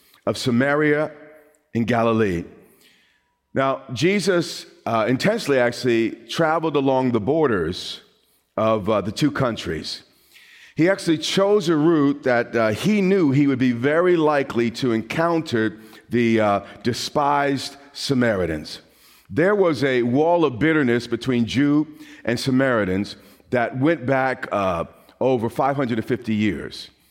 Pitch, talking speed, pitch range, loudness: 135 Hz, 120 wpm, 115-155 Hz, -21 LUFS